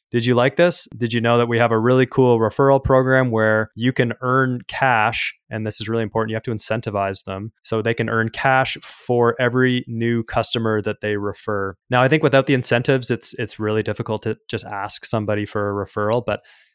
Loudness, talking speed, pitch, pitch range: -20 LUFS, 215 wpm, 115 Hz, 110-125 Hz